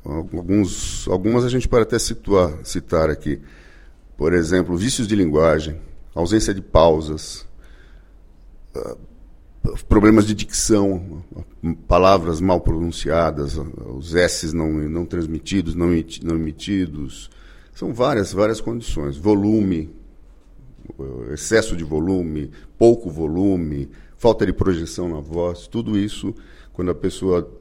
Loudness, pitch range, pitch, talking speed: -20 LUFS, 80-100 Hz, 85 Hz, 110 wpm